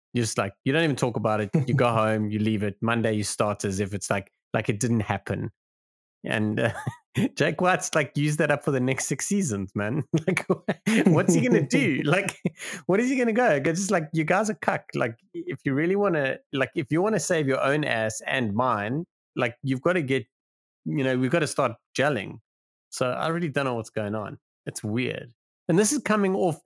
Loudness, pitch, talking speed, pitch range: -25 LUFS, 135 Hz, 220 wpm, 110-170 Hz